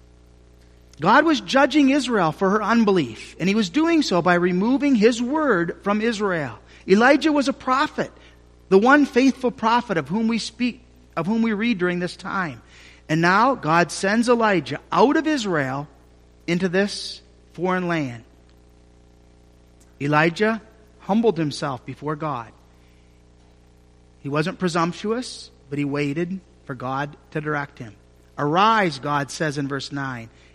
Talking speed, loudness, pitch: 140 wpm, -21 LUFS, 170 Hz